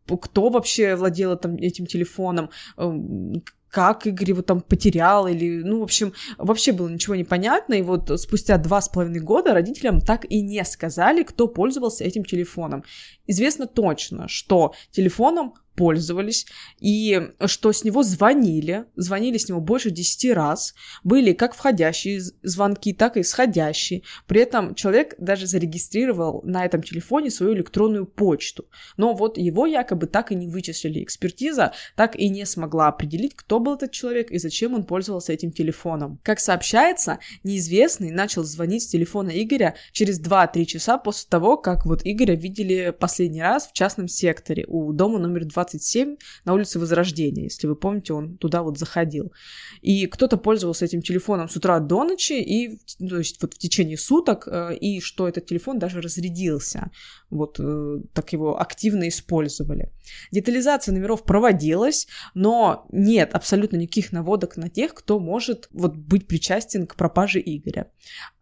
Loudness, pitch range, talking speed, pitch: -22 LUFS, 170-215 Hz, 150 wpm, 190 Hz